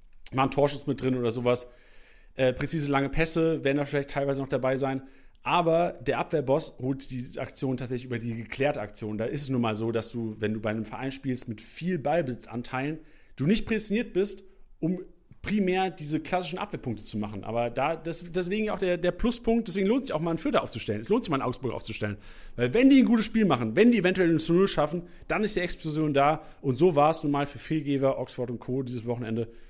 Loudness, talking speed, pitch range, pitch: -28 LUFS, 225 wpm, 125-175 Hz, 140 Hz